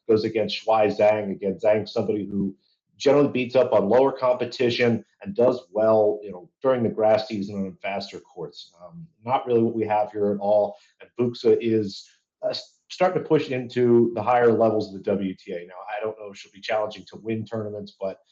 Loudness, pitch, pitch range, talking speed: -23 LUFS, 110 Hz, 105-125 Hz, 200 wpm